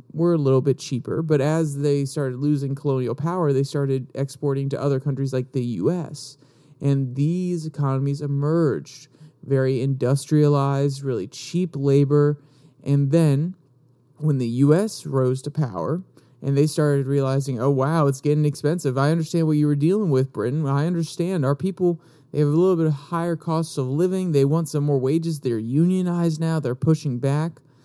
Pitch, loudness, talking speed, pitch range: 145 Hz, -22 LUFS, 170 wpm, 135-160 Hz